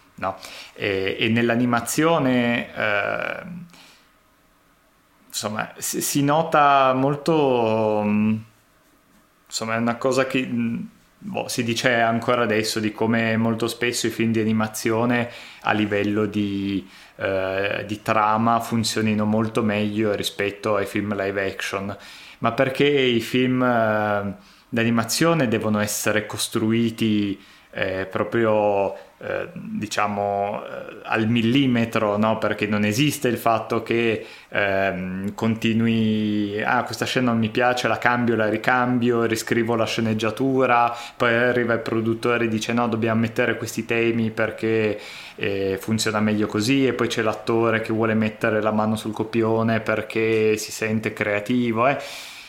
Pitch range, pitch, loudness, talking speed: 105-120 Hz, 115 Hz, -22 LUFS, 130 wpm